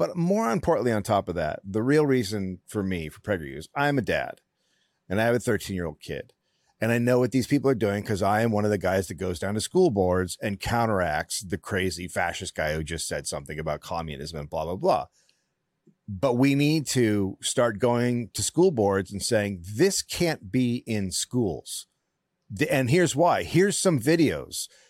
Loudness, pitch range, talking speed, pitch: -25 LUFS, 95-140 Hz, 200 wpm, 110 Hz